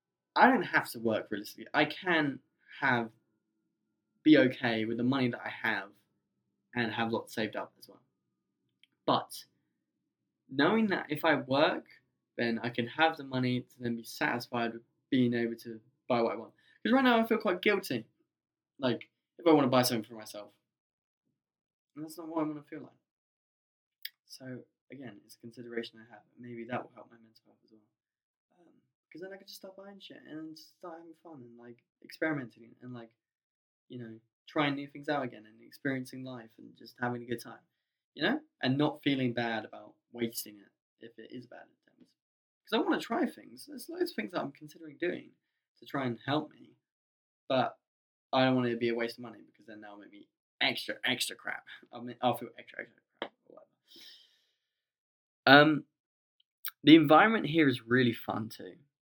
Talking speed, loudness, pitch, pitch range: 190 wpm, -30 LUFS, 125 Hz, 115-155 Hz